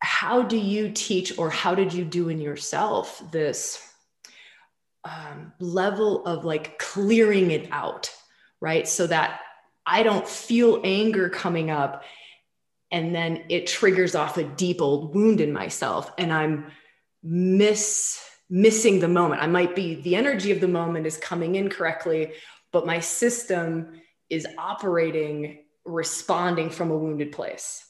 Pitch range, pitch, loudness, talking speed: 160-205 Hz, 175 Hz, -24 LUFS, 145 wpm